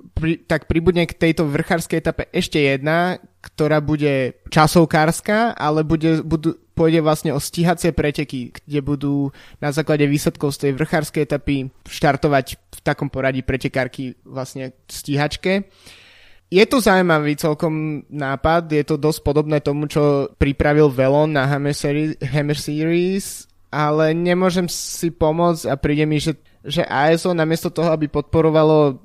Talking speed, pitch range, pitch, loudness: 135 wpm, 145-165 Hz, 150 Hz, -19 LUFS